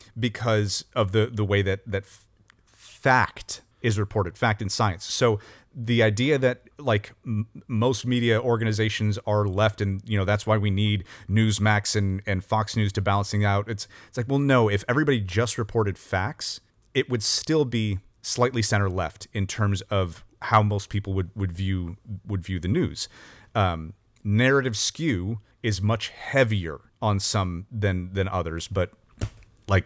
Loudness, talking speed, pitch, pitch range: -25 LUFS, 165 wpm, 105 Hz, 100-115 Hz